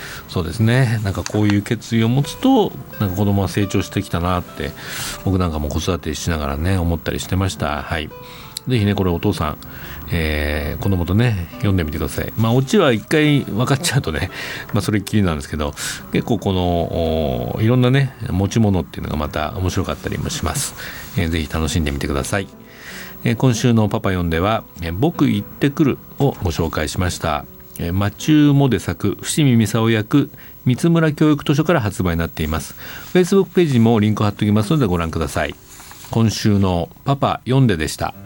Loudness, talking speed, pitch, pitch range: -19 LUFS, 395 characters per minute, 100 Hz, 85-125 Hz